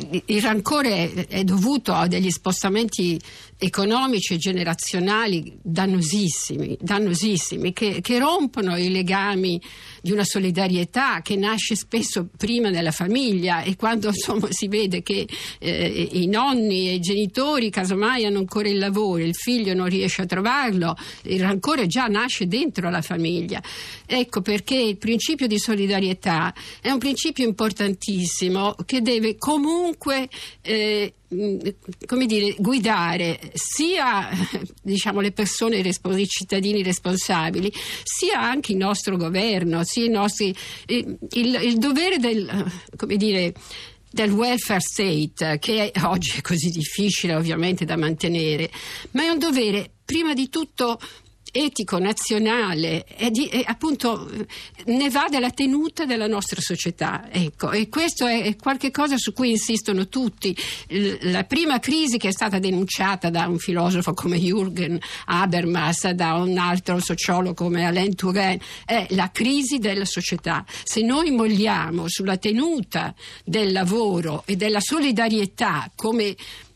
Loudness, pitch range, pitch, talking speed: -22 LUFS, 180-230 Hz, 200 Hz, 135 wpm